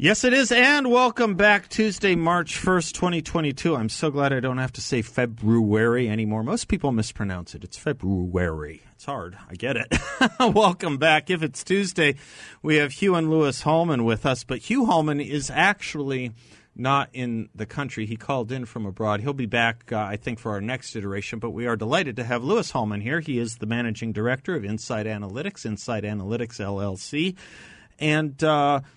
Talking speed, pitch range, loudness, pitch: 185 wpm, 110-160 Hz, -23 LUFS, 130 Hz